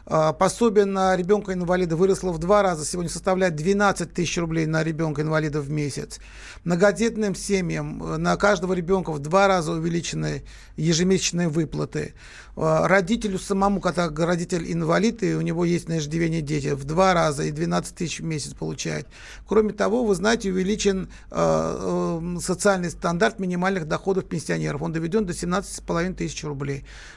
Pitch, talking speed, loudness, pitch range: 175 Hz, 145 wpm, -23 LUFS, 160-195 Hz